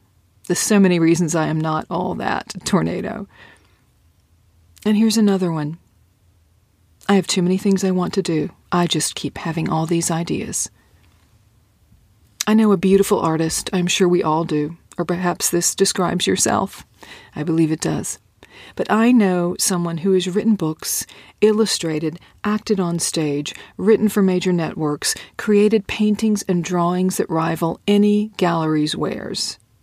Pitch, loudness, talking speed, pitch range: 170 Hz, -19 LUFS, 150 wpm, 150-195 Hz